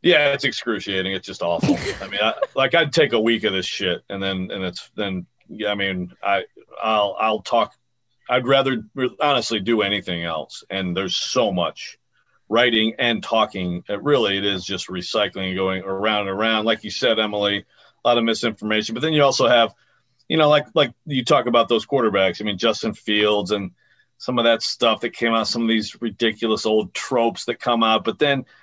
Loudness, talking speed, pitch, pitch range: -20 LUFS, 205 wpm, 110 Hz, 100-120 Hz